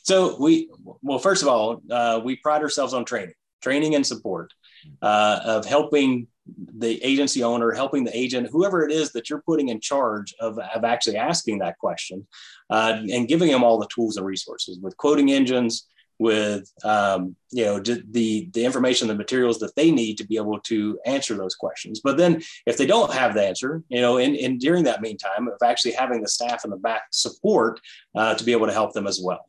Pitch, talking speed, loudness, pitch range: 120 Hz, 210 wpm, -22 LUFS, 110-140 Hz